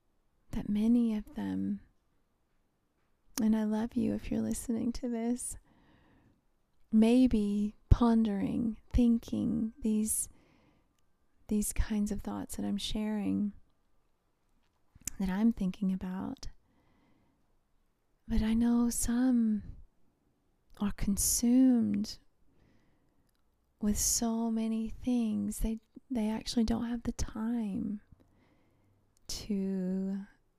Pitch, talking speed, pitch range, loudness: 220 Hz, 90 wpm, 205-235 Hz, -32 LUFS